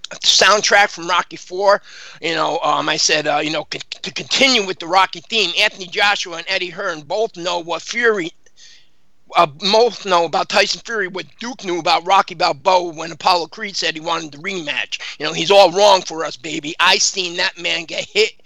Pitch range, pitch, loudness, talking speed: 175-210 Hz, 190 Hz, -16 LUFS, 200 wpm